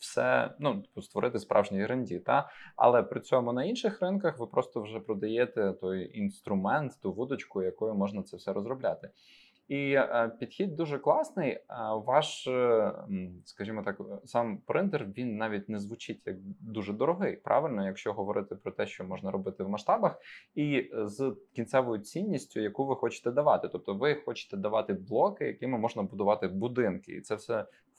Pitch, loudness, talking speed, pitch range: 120 Hz, -32 LUFS, 155 wpm, 105-140 Hz